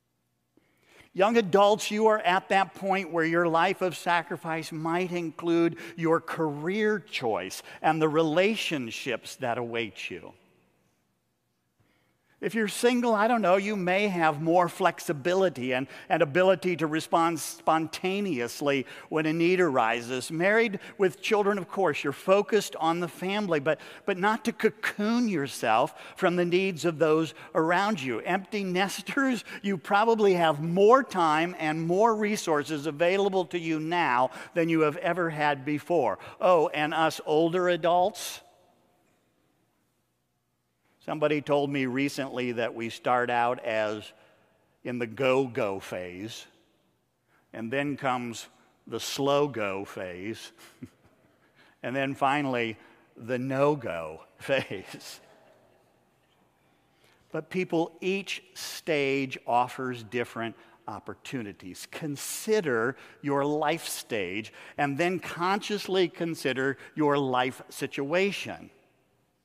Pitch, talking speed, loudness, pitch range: 165 Hz, 120 wpm, -27 LUFS, 135-185 Hz